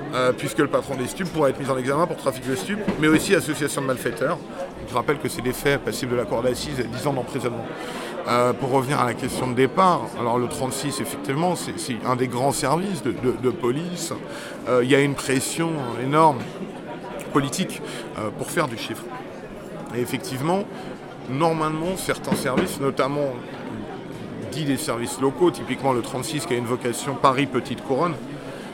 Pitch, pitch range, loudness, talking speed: 135 Hz, 125-150 Hz, -24 LUFS, 190 wpm